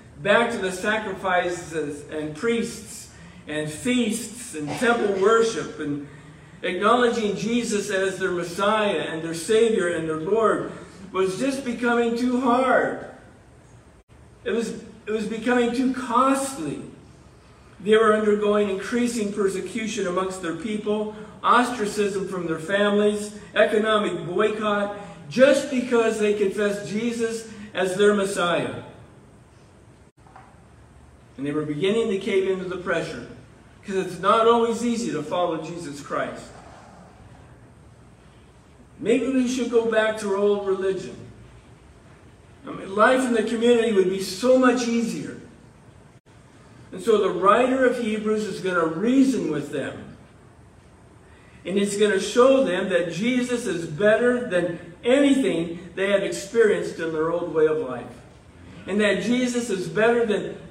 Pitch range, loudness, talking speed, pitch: 185-230 Hz, -23 LUFS, 130 wpm, 210 Hz